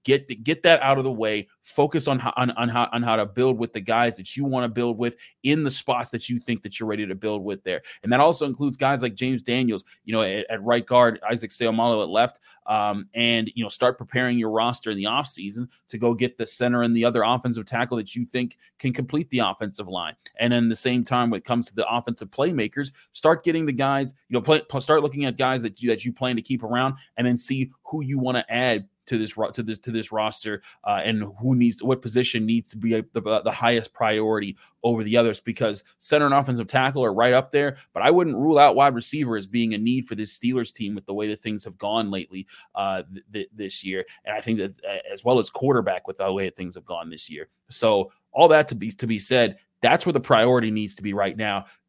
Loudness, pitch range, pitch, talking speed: -23 LUFS, 110-130 Hz, 120 Hz, 255 wpm